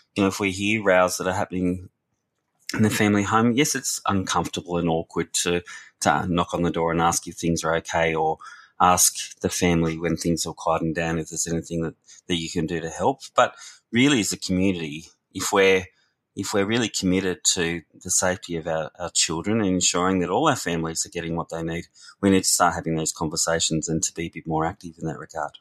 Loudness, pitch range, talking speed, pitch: -23 LUFS, 80-95 Hz, 225 wpm, 85 Hz